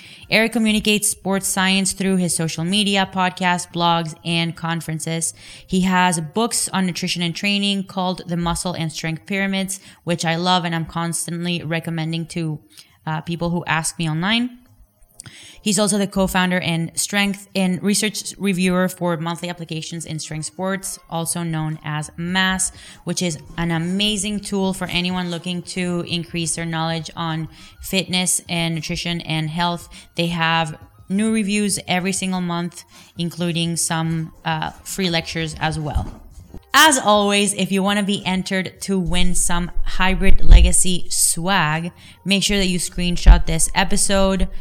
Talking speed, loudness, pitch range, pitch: 150 wpm, -20 LUFS, 165-190 Hz, 175 Hz